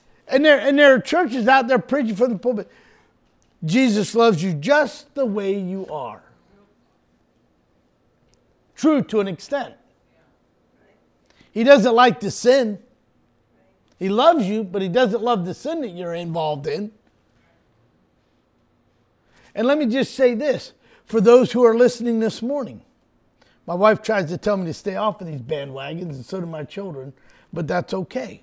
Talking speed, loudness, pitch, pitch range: 160 wpm, -19 LUFS, 220 Hz, 185-255 Hz